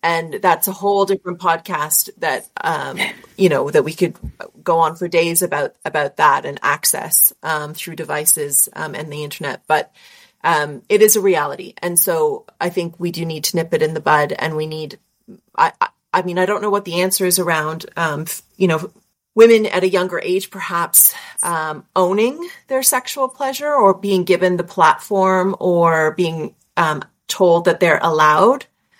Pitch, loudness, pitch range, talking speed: 180 Hz, -16 LUFS, 160-205 Hz, 180 wpm